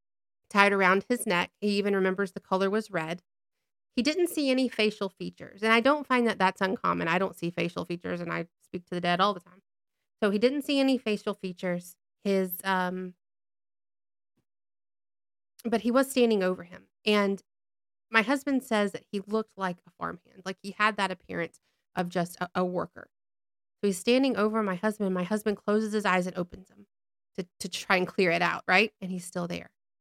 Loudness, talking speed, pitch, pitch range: -28 LUFS, 200 wpm, 190 Hz, 175-215 Hz